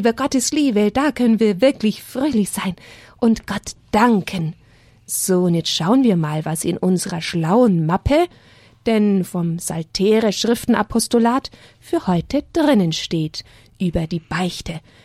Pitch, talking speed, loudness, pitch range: 190 Hz, 130 wpm, -19 LUFS, 165-235 Hz